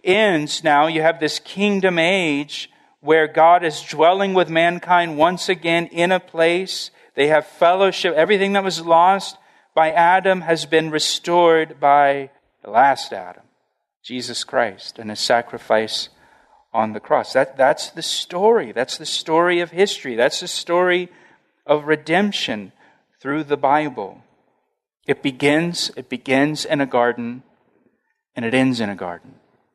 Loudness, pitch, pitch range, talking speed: -18 LUFS, 160 Hz, 145-175 Hz, 145 wpm